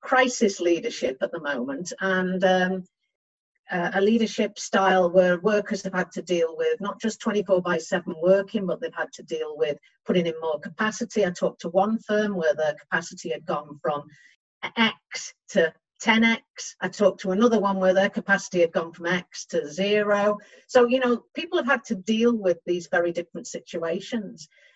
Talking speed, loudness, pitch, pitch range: 180 wpm, -24 LUFS, 195 Hz, 175-220 Hz